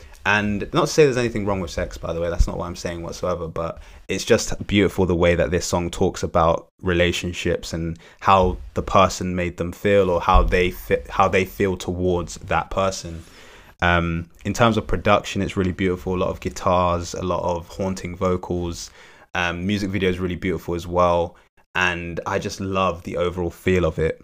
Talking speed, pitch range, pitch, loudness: 200 wpm, 85-95 Hz, 90 Hz, -22 LUFS